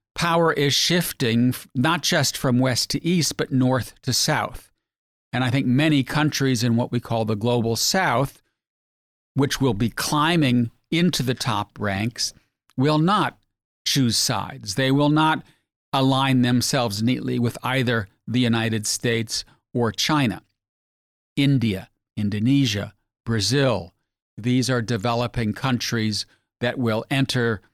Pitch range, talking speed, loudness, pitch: 110-135 Hz, 130 wpm, -22 LUFS, 125 Hz